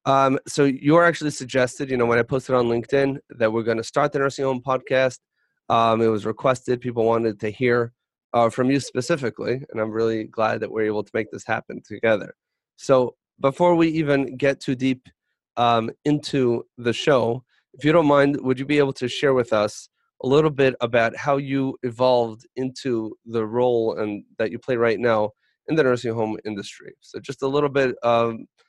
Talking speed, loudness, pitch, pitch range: 200 wpm, -22 LUFS, 125 Hz, 115-140 Hz